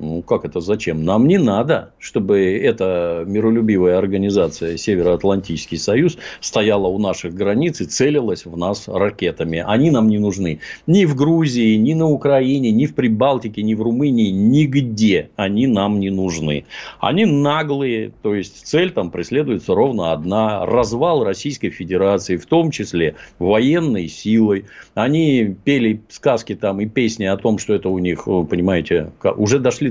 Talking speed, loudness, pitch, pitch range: 150 wpm, -17 LUFS, 105 Hz, 95-135 Hz